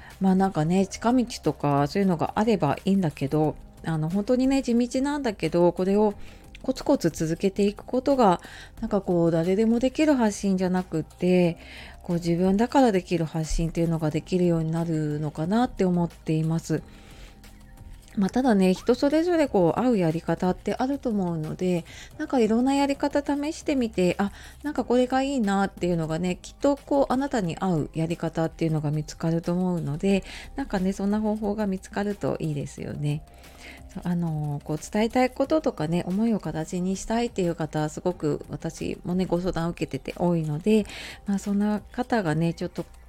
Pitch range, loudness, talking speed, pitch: 165-230 Hz, -25 LUFS, 385 characters per minute, 185 Hz